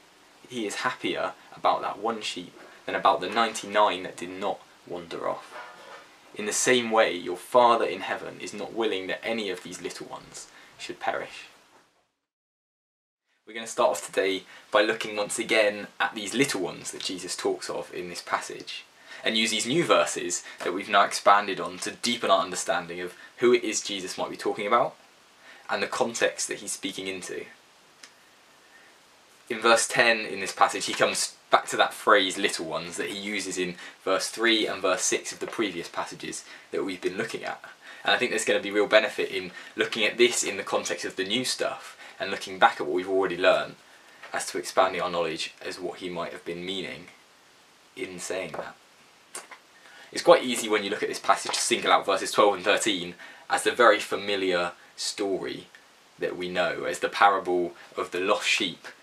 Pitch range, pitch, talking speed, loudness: 90-130 Hz, 105 Hz, 195 wpm, -26 LUFS